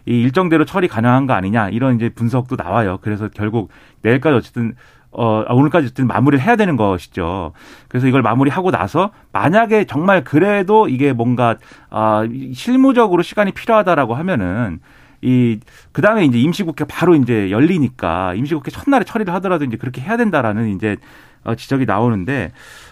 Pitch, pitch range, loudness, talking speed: 130 Hz, 115-170 Hz, -16 LUFS, 400 characters per minute